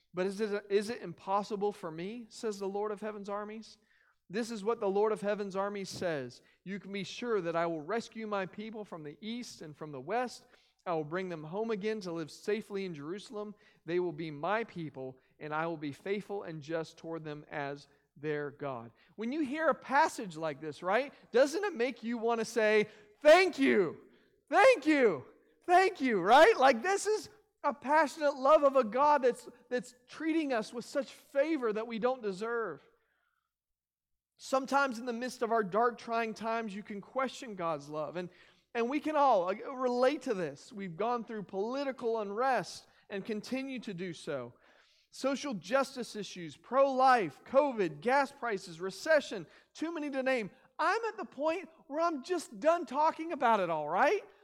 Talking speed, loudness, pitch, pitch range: 185 wpm, -32 LUFS, 220 Hz, 185-265 Hz